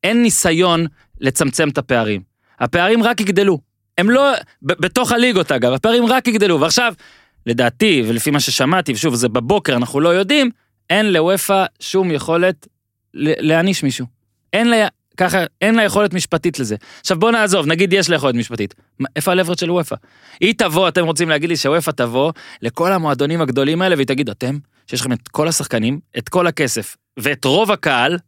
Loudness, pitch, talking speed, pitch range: -16 LUFS, 165 Hz, 170 wpm, 130-190 Hz